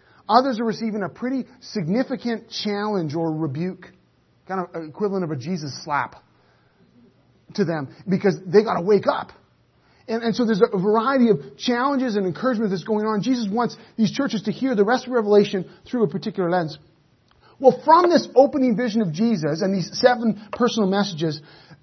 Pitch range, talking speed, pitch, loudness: 180-235 Hz, 170 wpm, 210 Hz, -22 LUFS